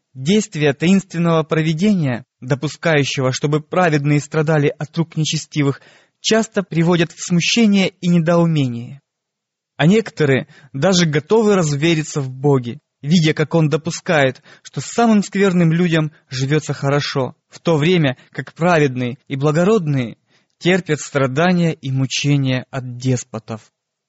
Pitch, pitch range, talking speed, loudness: 155 Hz, 140-175 Hz, 115 wpm, -17 LUFS